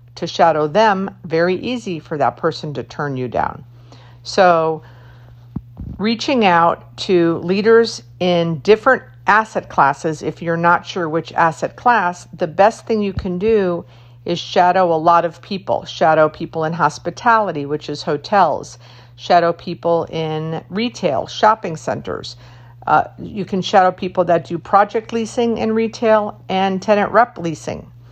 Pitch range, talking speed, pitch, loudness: 150-200 Hz, 145 wpm, 170 Hz, -17 LUFS